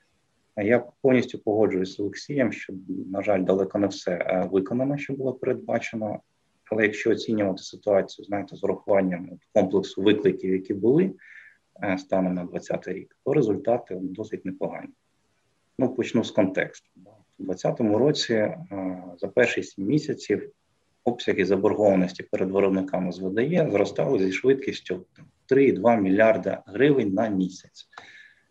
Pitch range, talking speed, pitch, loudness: 95-105 Hz, 125 wpm, 95 Hz, -25 LUFS